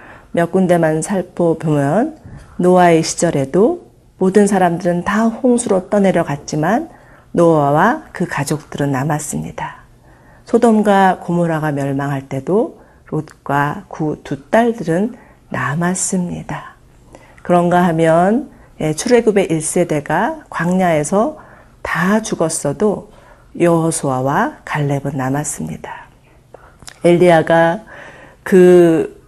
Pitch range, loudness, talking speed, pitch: 150-195 Hz, -15 LUFS, 220 characters per minute, 170 Hz